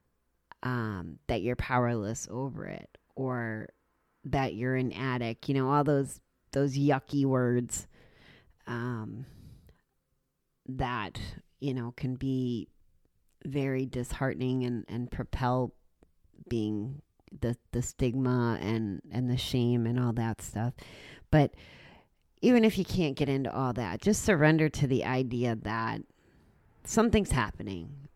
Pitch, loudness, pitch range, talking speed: 125 Hz, -31 LUFS, 110-135 Hz, 125 wpm